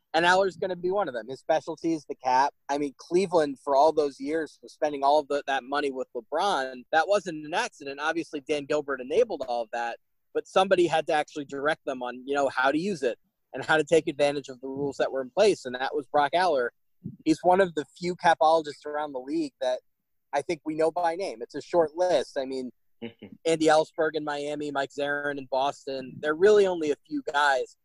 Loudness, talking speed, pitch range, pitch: -27 LUFS, 230 wpm, 140-175 Hz, 150 Hz